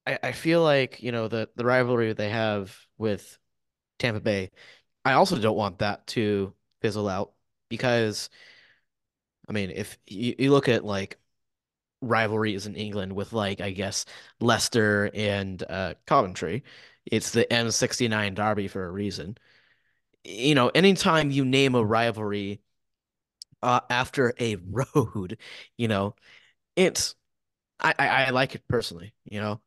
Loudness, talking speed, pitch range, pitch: -25 LUFS, 150 wpm, 105-125 Hz, 110 Hz